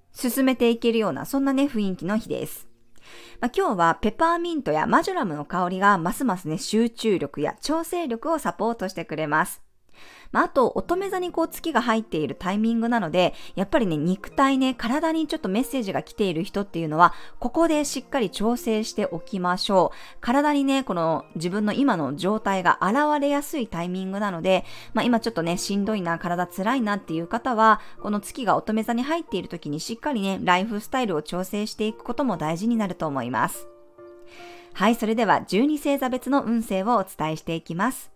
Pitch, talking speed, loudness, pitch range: 215 Hz, 405 characters per minute, -24 LUFS, 175-255 Hz